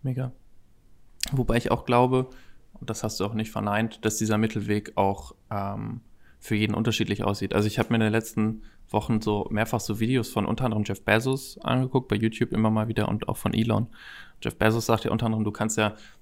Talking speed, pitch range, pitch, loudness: 210 wpm, 105-115 Hz, 110 Hz, -26 LUFS